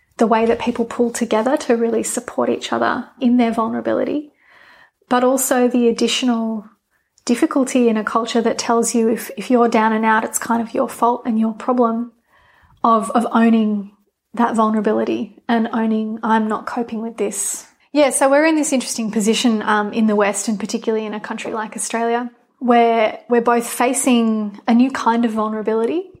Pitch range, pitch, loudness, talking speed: 220-245 Hz, 230 Hz, -18 LUFS, 180 wpm